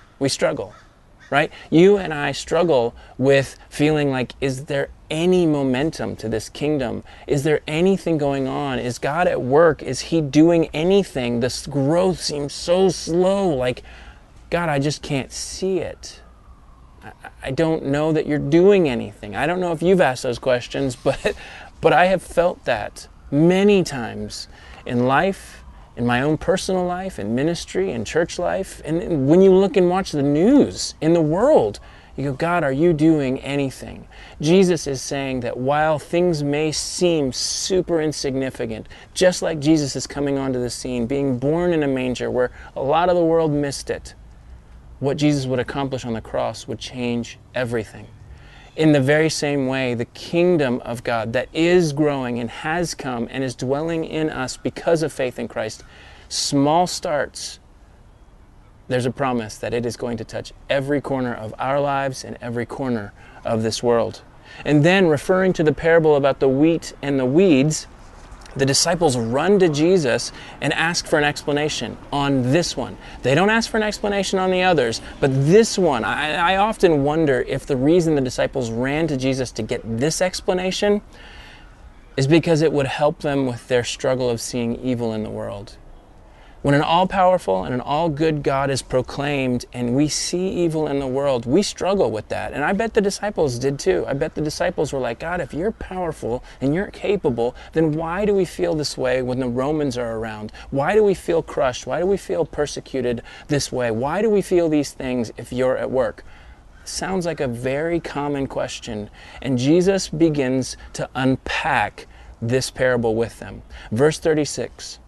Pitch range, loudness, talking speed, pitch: 125-165 Hz, -20 LUFS, 180 wpm, 140 Hz